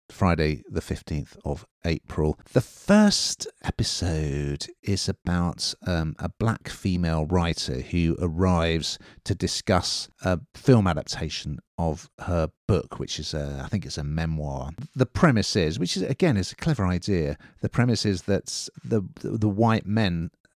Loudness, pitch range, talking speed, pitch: -26 LUFS, 80-105 Hz, 150 wpm, 90 Hz